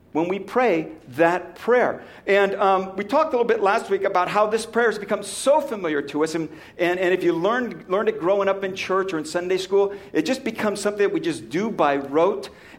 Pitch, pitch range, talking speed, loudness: 195 Hz, 175-215 Hz, 235 wpm, -22 LUFS